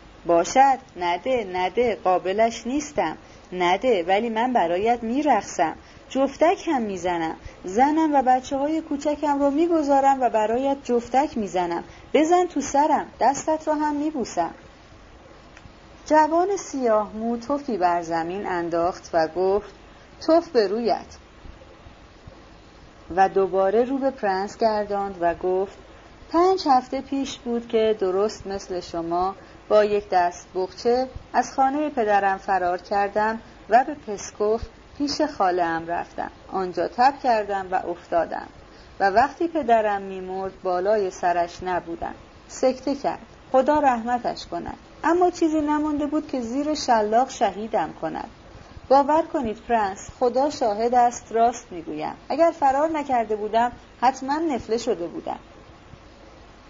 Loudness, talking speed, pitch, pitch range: -23 LUFS, 125 wpm, 235 Hz, 195-285 Hz